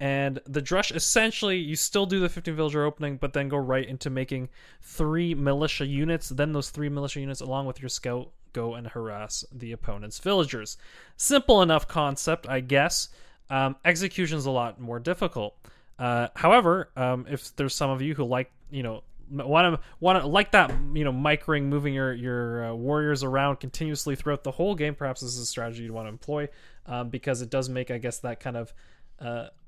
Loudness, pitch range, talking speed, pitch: -27 LUFS, 125-155 Hz, 200 wpm, 140 Hz